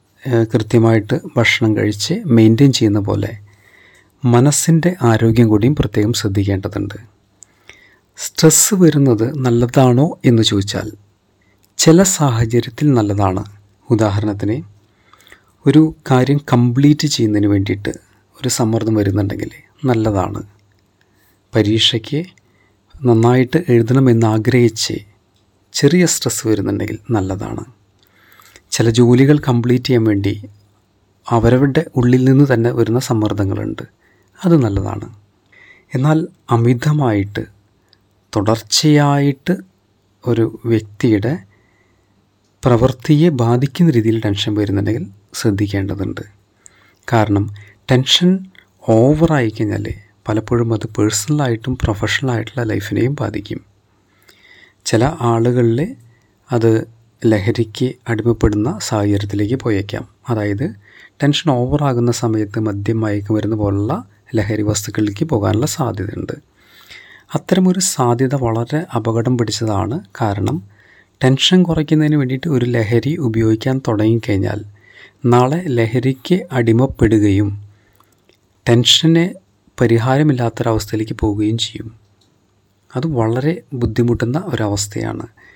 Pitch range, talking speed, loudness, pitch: 105-130 Hz, 80 wpm, -15 LUFS, 115 Hz